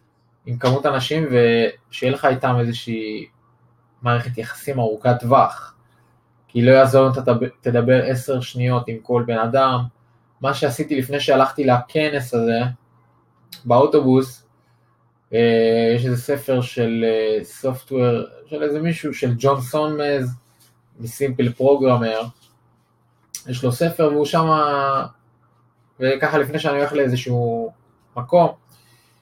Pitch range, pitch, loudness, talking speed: 120-135 Hz, 125 Hz, -19 LUFS, 115 wpm